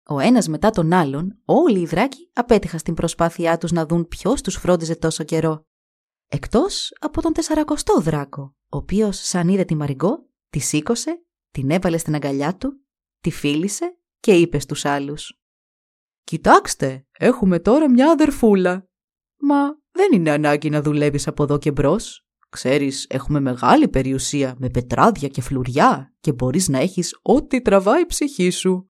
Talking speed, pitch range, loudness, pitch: 155 wpm, 145-240 Hz, -19 LUFS, 170 Hz